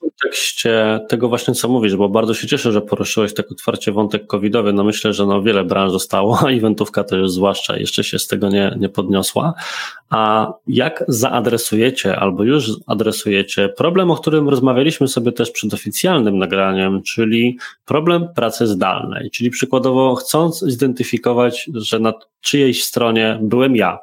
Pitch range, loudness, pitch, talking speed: 105-130 Hz, -16 LUFS, 115 Hz, 160 wpm